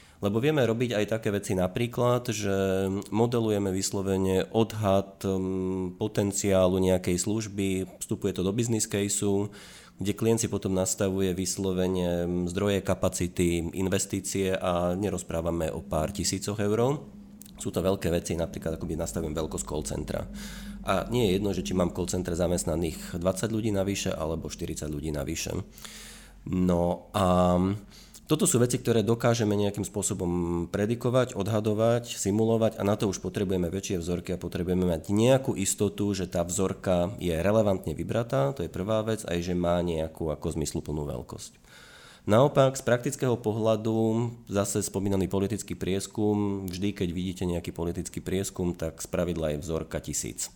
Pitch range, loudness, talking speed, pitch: 90-105 Hz, -28 LUFS, 145 wpm, 95 Hz